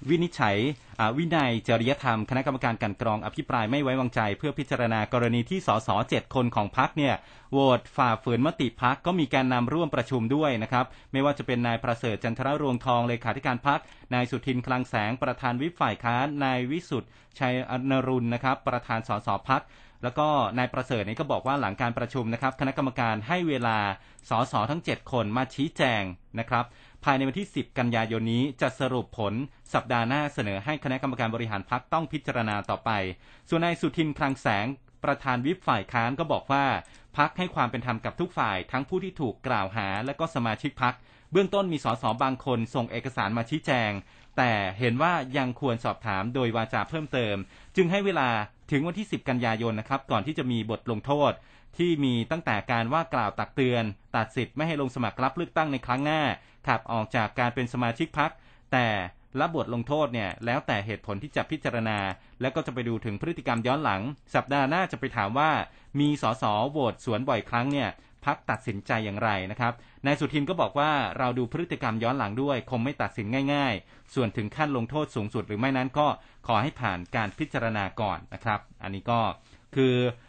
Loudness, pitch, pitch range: -28 LUFS, 125 Hz, 115-140 Hz